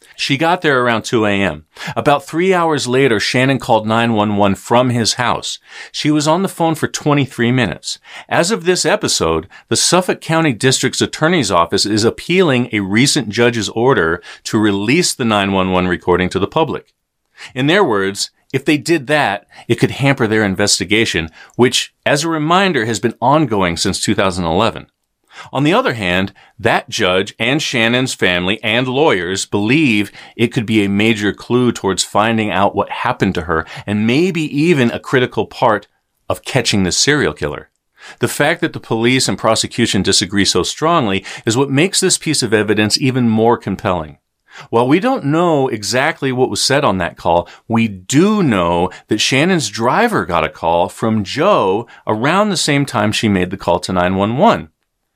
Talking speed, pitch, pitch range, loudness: 170 wpm, 115 Hz, 100-145 Hz, -15 LUFS